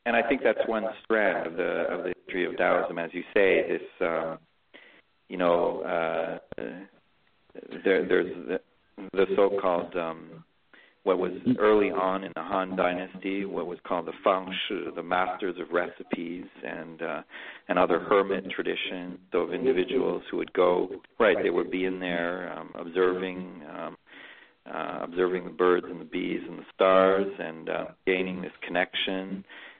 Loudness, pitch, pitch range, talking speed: -28 LUFS, 95 Hz, 90-115 Hz, 160 wpm